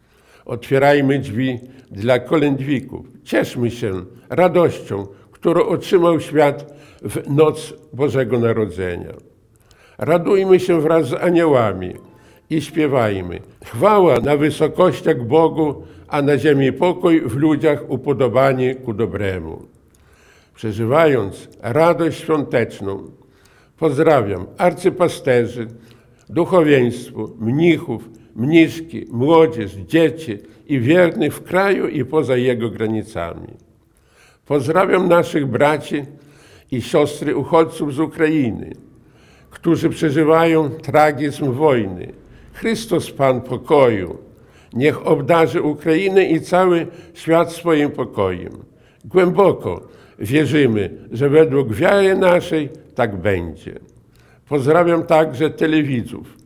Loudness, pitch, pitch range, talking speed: -17 LUFS, 145 Hz, 120-160 Hz, 90 wpm